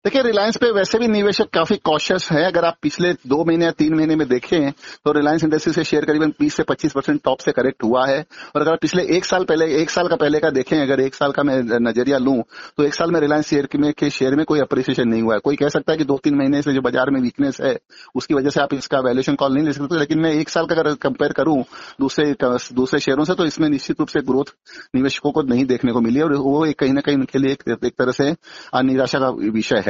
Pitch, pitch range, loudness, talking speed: 150 Hz, 135-160 Hz, -18 LUFS, 265 wpm